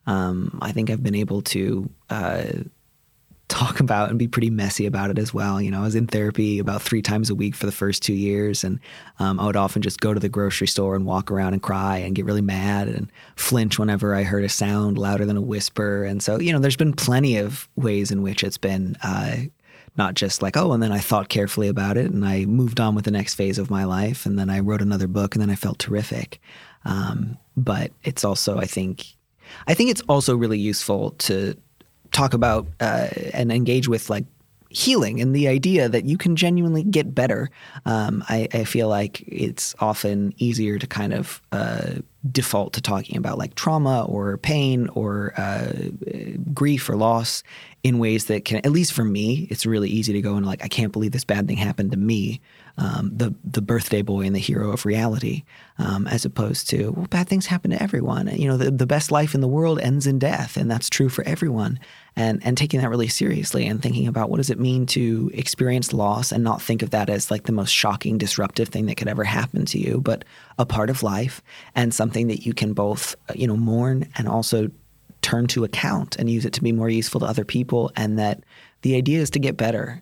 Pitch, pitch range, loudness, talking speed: 110 Hz, 100-130 Hz, -22 LUFS, 225 wpm